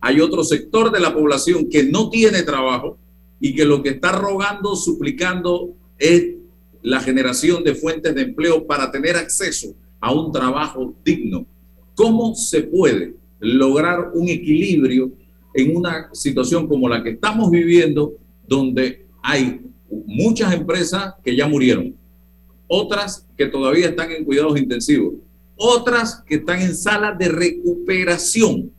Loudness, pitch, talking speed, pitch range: -18 LUFS, 155 Hz, 140 wpm, 130-180 Hz